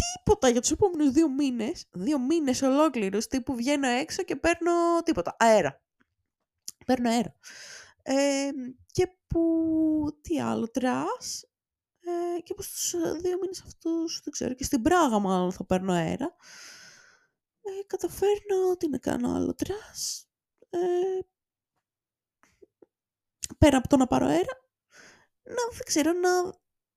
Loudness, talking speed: -27 LUFS, 130 wpm